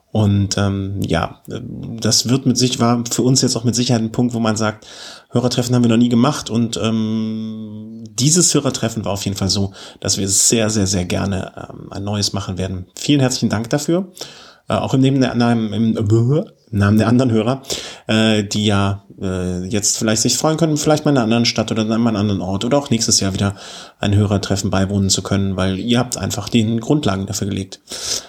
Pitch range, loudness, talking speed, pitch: 100-120 Hz, -17 LUFS, 210 wpm, 110 Hz